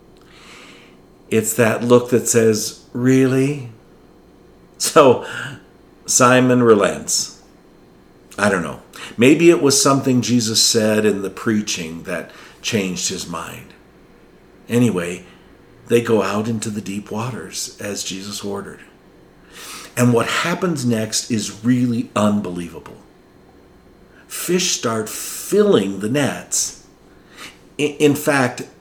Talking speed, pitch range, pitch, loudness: 105 wpm, 105-130 Hz, 115 Hz, -17 LUFS